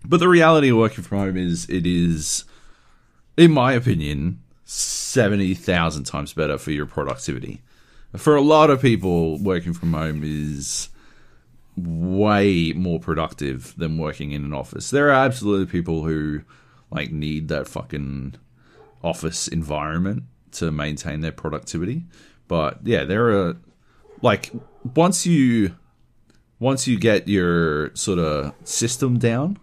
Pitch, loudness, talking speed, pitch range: 90 Hz, -21 LUFS, 135 wpm, 75-120 Hz